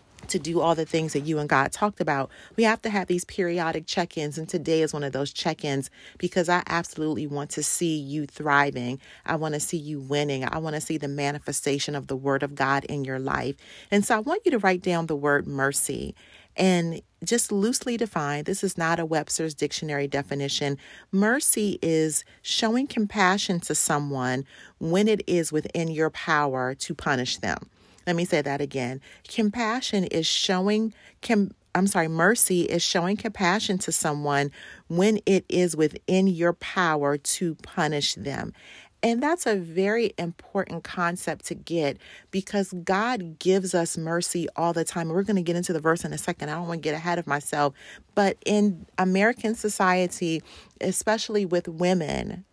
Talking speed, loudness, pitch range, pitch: 180 wpm, -25 LUFS, 150-195 Hz, 170 Hz